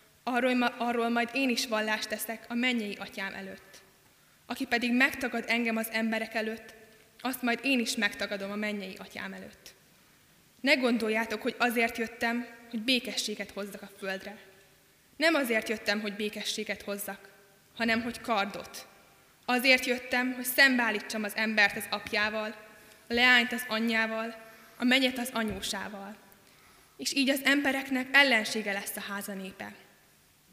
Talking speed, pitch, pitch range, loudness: 135 wpm, 225 Hz, 210-245 Hz, -28 LUFS